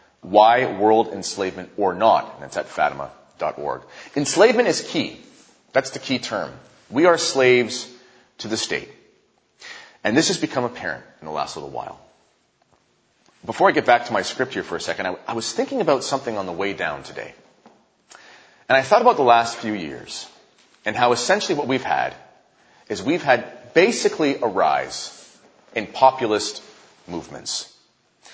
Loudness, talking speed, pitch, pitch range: -21 LUFS, 165 wpm, 120 Hz, 110-130 Hz